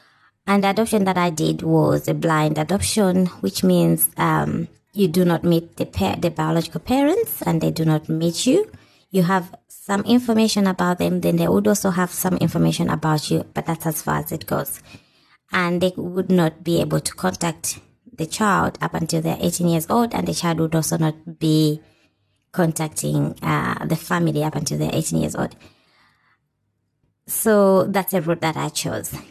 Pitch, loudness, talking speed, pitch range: 165 Hz, -20 LUFS, 185 wpm, 150-185 Hz